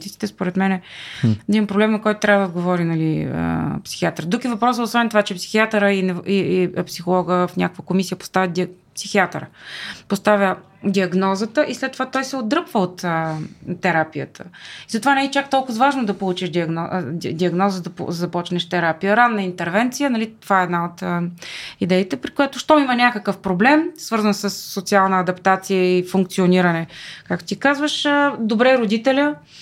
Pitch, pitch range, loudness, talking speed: 195 Hz, 180-230 Hz, -19 LUFS, 165 wpm